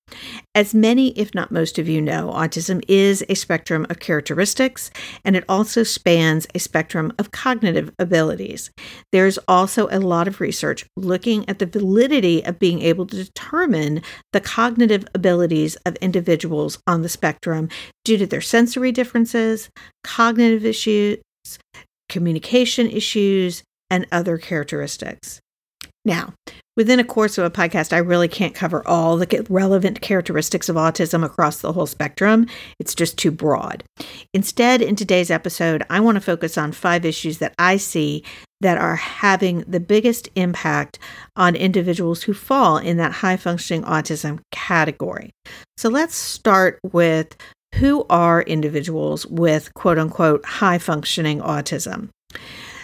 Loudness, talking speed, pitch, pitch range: -19 LUFS, 145 wpm, 180 Hz, 165-210 Hz